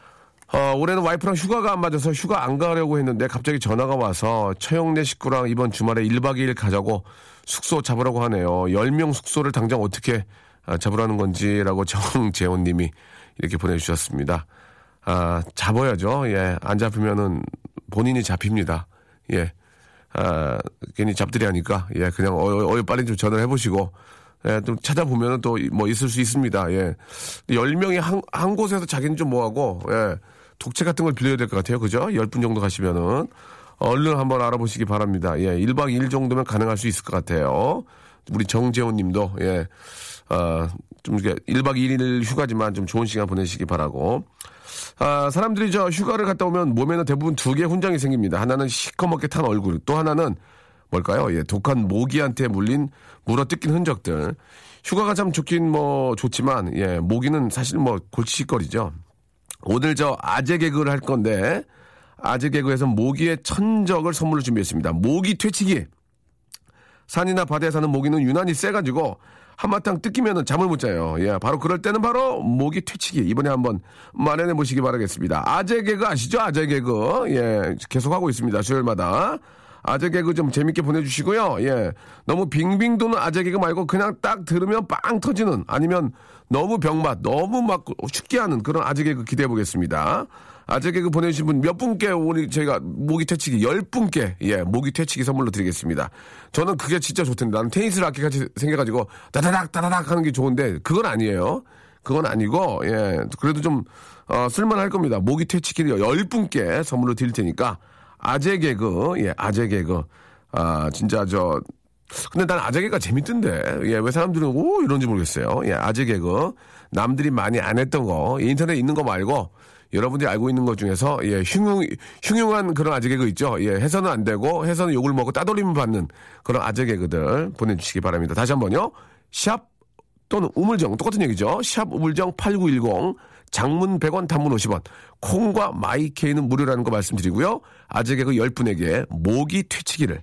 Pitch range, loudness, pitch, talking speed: 105-160 Hz, -22 LUFS, 130 Hz, 350 characters per minute